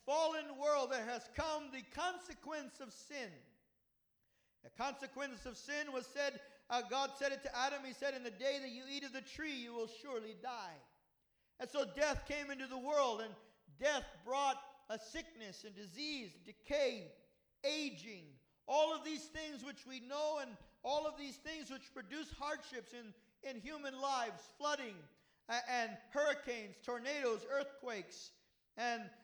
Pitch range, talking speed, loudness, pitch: 240-290 Hz, 160 wpm, -42 LUFS, 270 Hz